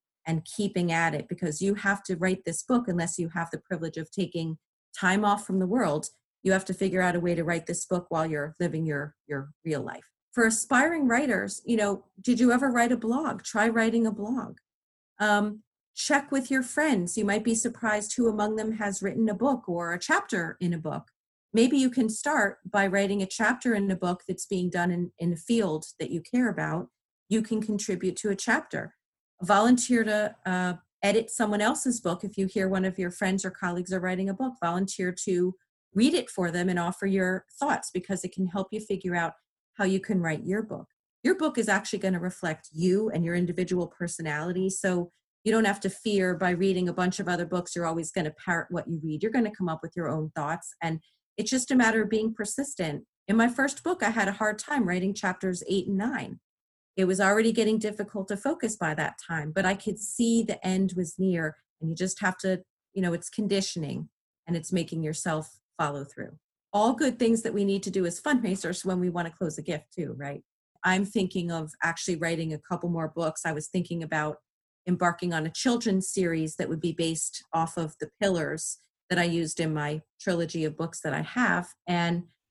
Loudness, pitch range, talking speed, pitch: -28 LUFS, 170-215 Hz, 220 wpm, 185 Hz